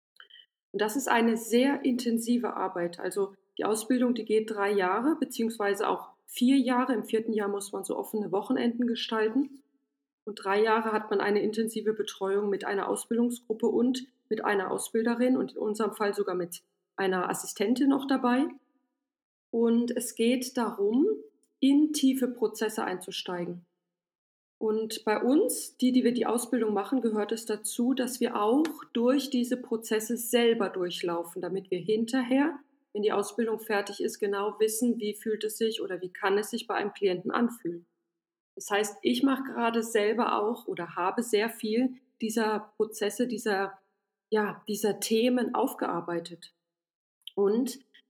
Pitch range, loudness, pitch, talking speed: 200-245 Hz, -29 LUFS, 220 Hz, 150 wpm